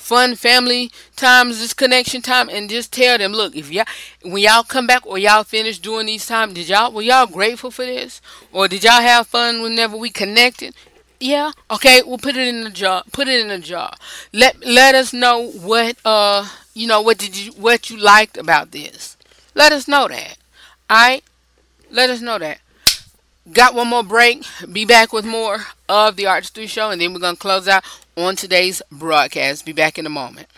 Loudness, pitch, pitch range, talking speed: -14 LUFS, 230 Hz, 205-250 Hz, 200 wpm